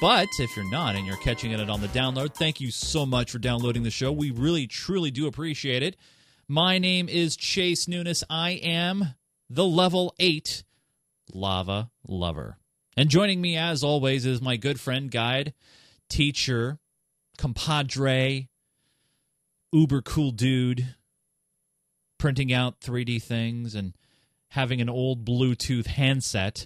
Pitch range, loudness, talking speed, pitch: 120-160 Hz, -26 LUFS, 140 wpm, 135 Hz